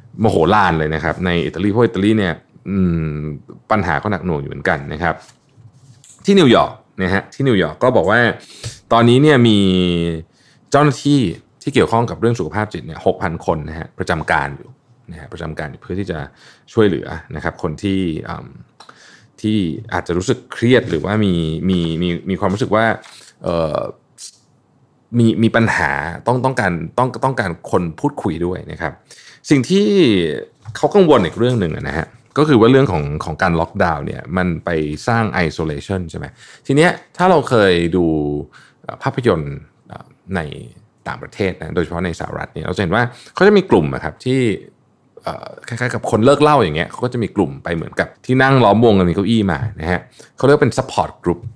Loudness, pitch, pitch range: -16 LUFS, 105 Hz, 85-125 Hz